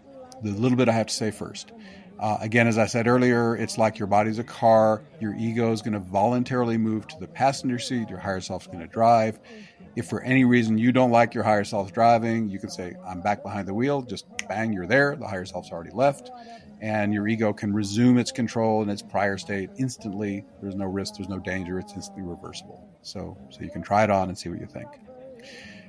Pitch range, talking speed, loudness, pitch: 100-125 Hz, 230 wpm, -24 LUFS, 110 Hz